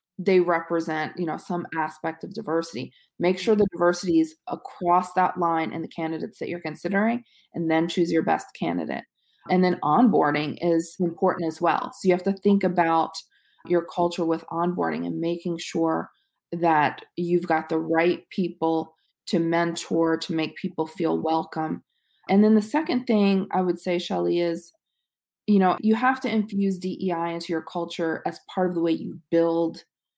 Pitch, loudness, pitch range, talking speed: 175 Hz, -25 LUFS, 165-190 Hz, 175 wpm